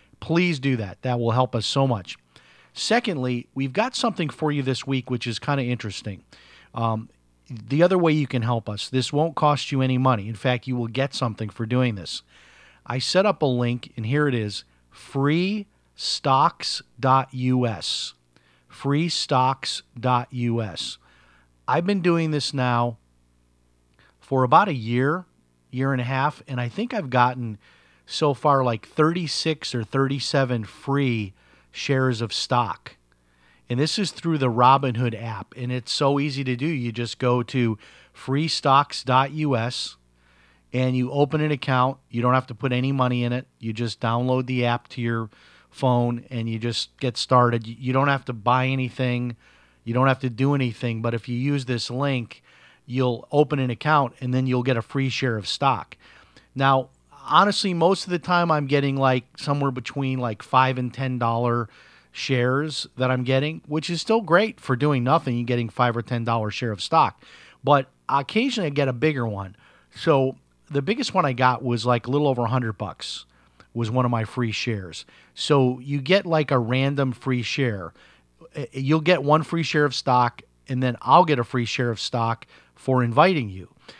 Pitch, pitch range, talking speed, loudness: 125 Hz, 115-140 Hz, 180 wpm, -23 LUFS